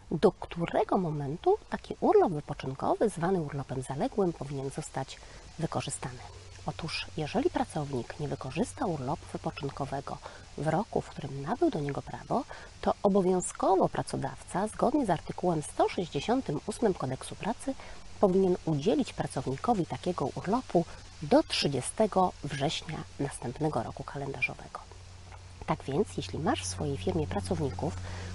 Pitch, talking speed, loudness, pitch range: 155 Hz, 115 wpm, -31 LUFS, 130-190 Hz